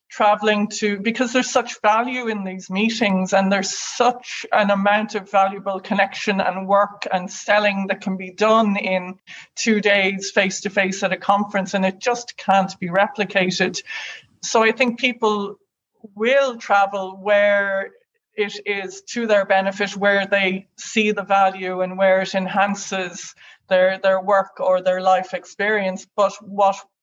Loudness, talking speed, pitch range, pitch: -20 LUFS, 155 wpm, 190-210 Hz, 200 Hz